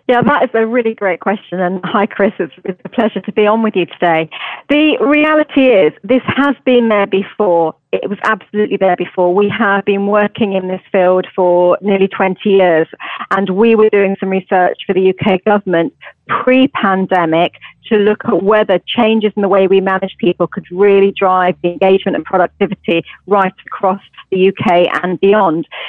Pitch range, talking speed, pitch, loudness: 185-210 Hz, 180 wpm, 195 Hz, -13 LUFS